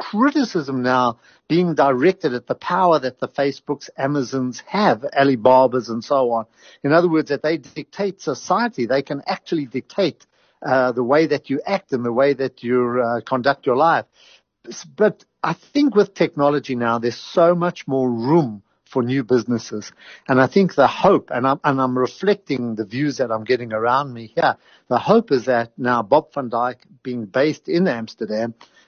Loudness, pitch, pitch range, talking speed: -19 LUFS, 135 Hz, 125-160 Hz, 180 wpm